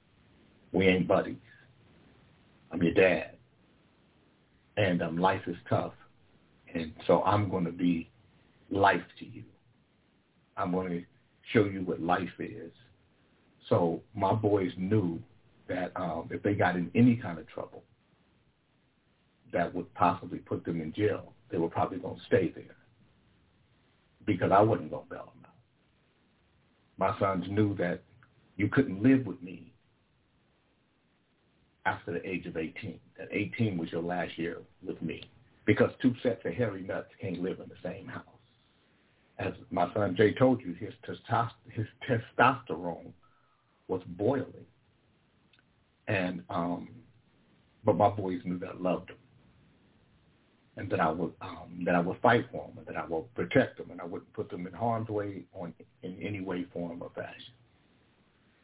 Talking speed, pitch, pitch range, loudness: 155 wpm, 95 Hz, 90-105 Hz, -31 LUFS